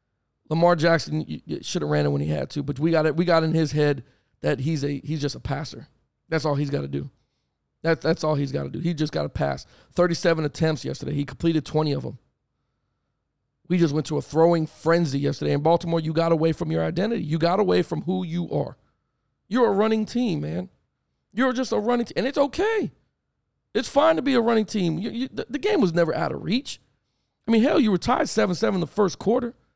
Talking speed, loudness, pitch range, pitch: 230 wpm, -24 LUFS, 150-215 Hz, 165 Hz